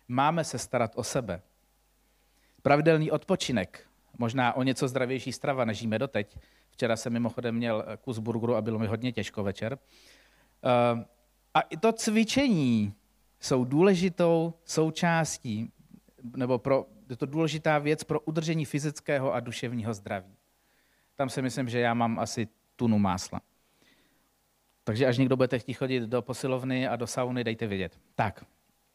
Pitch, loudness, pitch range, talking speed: 125 Hz, -29 LUFS, 115-145 Hz, 145 wpm